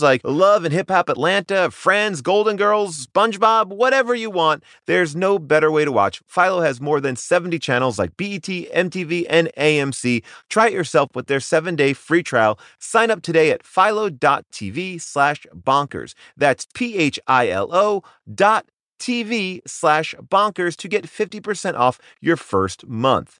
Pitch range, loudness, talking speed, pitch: 145-205 Hz, -19 LUFS, 150 wpm, 175 Hz